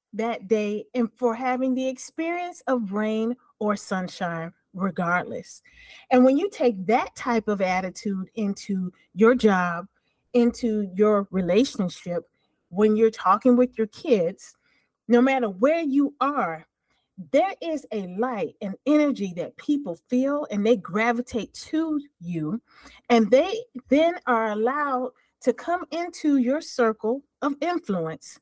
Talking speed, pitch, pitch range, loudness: 135 wpm, 240 Hz, 205-275 Hz, -24 LUFS